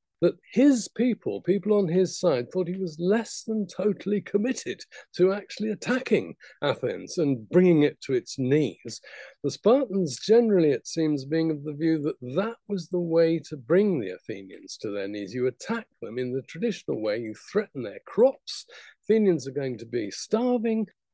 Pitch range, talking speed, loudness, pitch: 150-215 Hz, 175 wpm, -26 LUFS, 185 Hz